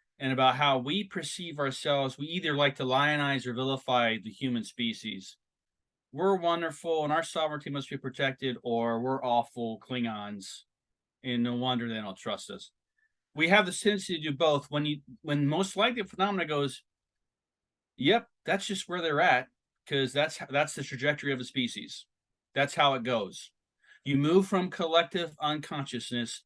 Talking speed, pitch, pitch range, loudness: 170 wpm, 145 Hz, 130-165 Hz, -29 LUFS